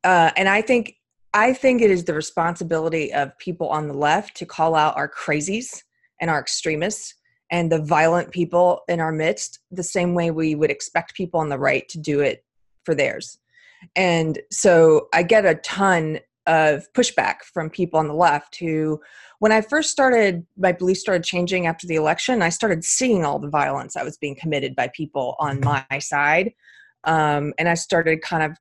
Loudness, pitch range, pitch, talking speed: -20 LUFS, 155-190 Hz, 170 Hz, 190 wpm